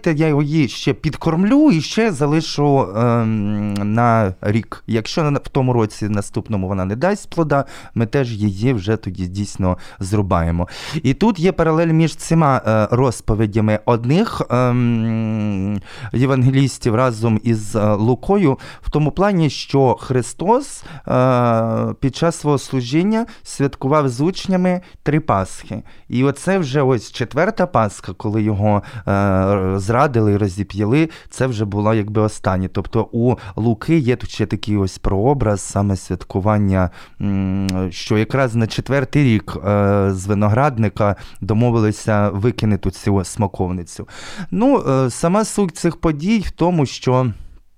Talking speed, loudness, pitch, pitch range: 130 wpm, -18 LUFS, 115 Hz, 105-145 Hz